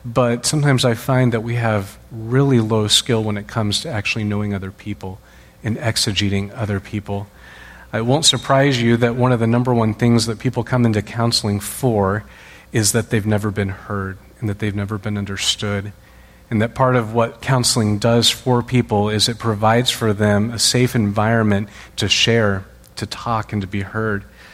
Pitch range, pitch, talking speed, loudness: 105-120 Hz, 110 Hz, 185 wpm, -18 LUFS